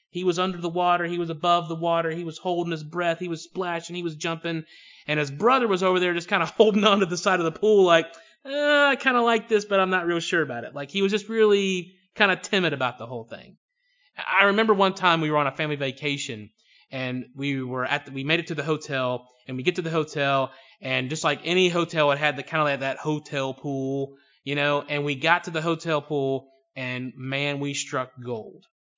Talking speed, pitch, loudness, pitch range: 245 wpm, 165 Hz, -24 LUFS, 140-185 Hz